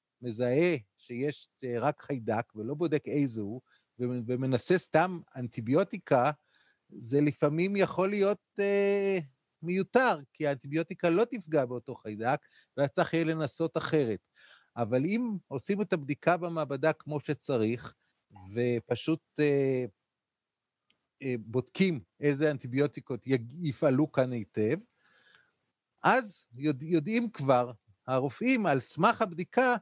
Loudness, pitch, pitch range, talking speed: -30 LUFS, 145 Hz, 125-175 Hz, 100 wpm